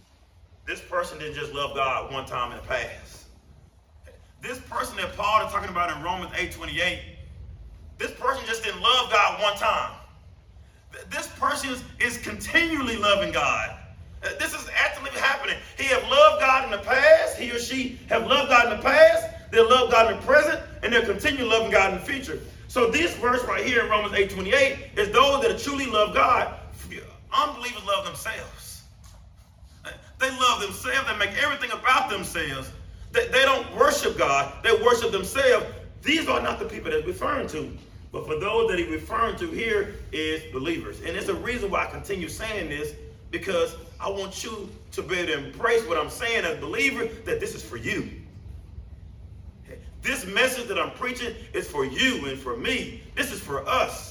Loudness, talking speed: -23 LUFS, 185 wpm